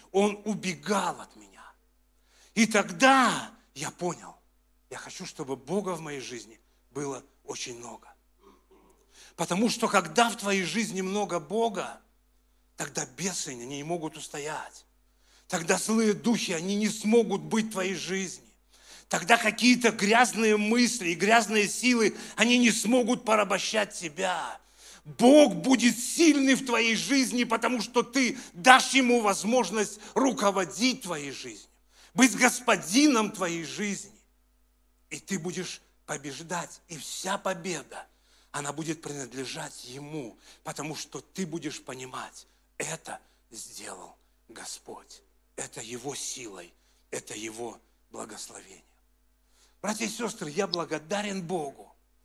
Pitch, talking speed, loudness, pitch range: 195 Hz, 120 wpm, -26 LUFS, 155-230 Hz